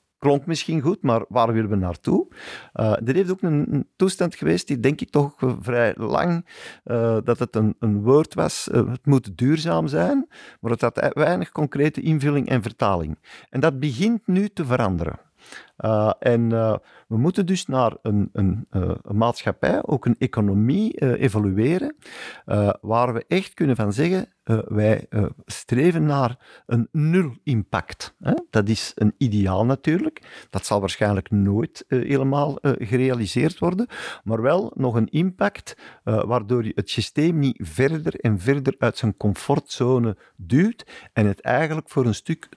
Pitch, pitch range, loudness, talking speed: 125 Hz, 110-155 Hz, -22 LUFS, 165 wpm